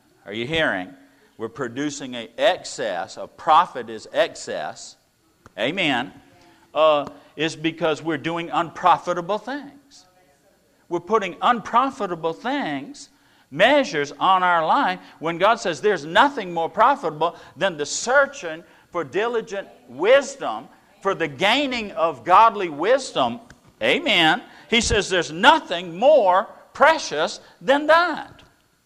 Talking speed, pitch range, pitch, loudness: 115 wpm, 160-260 Hz, 185 Hz, -21 LUFS